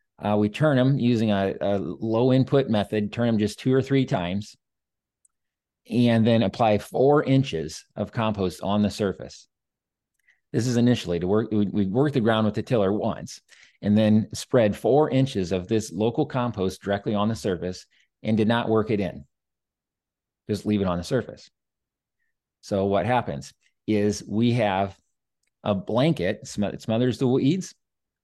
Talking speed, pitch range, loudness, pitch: 170 wpm, 100-120 Hz, -24 LUFS, 110 Hz